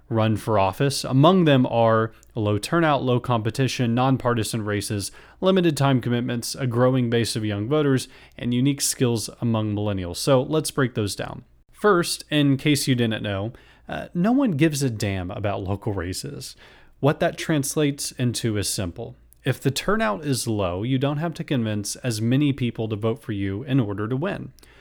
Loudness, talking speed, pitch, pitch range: -23 LUFS, 175 wpm, 125 Hz, 110-140 Hz